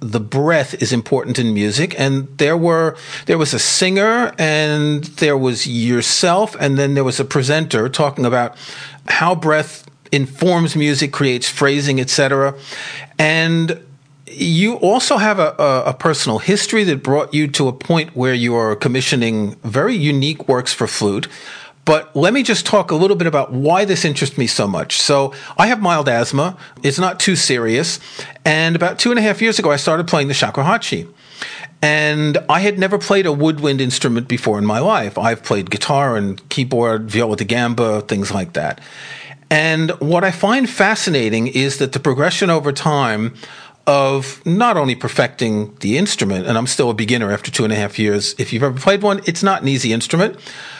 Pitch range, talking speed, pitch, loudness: 125-165 Hz, 180 wpm, 145 Hz, -16 LUFS